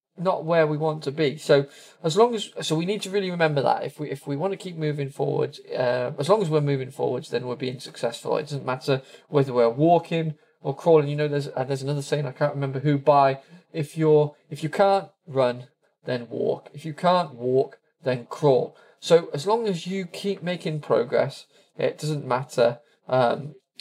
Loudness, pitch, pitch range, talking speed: -24 LUFS, 150 Hz, 135-170 Hz, 210 wpm